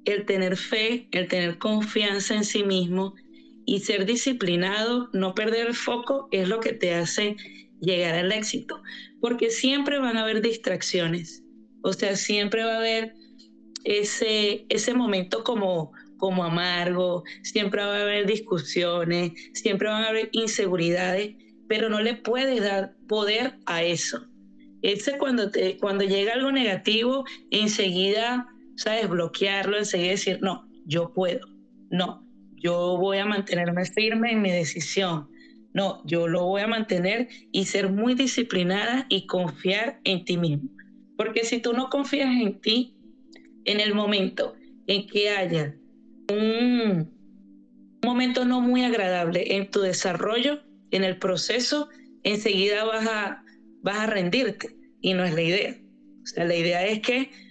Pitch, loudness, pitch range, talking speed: 210 Hz, -25 LUFS, 185-235 Hz, 145 wpm